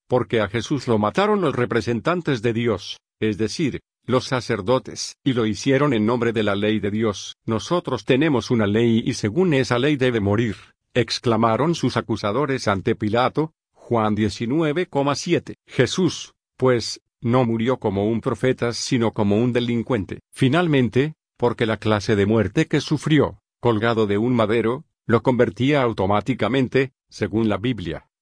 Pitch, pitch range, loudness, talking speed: 120 Hz, 110-130 Hz, -21 LUFS, 145 wpm